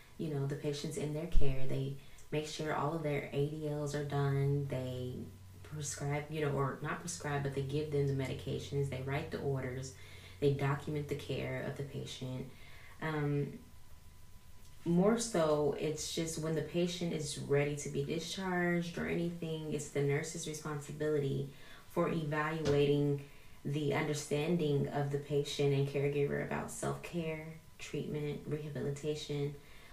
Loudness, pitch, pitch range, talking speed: -37 LUFS, 145 Hz, 140-150 Hz, 145 wpm